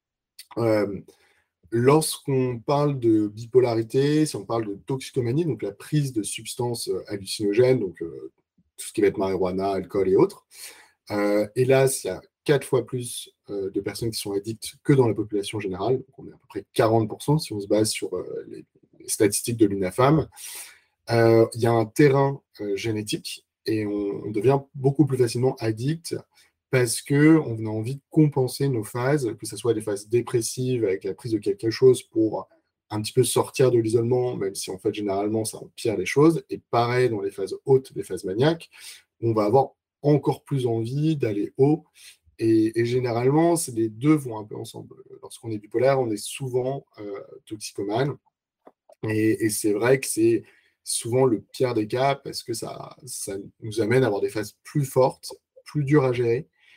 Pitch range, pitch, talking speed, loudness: 110-150 Hz, 130 Hz, 185 wpm, -24 LUFS